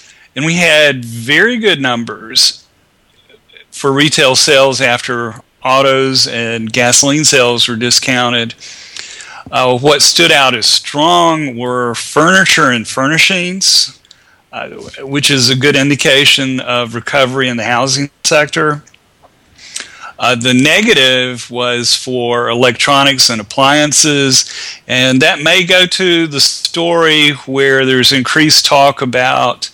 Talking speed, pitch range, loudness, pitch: 115 wpm, 125-150 Hz, -9 LUFS, 135 Hz